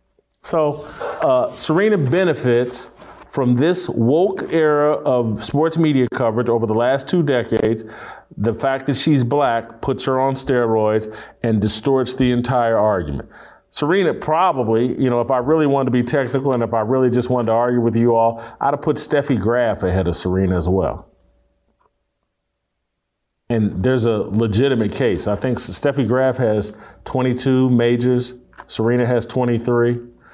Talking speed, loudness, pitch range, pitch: 155 wpm, -18 LUFS, 115-135 Hz, 125 Hz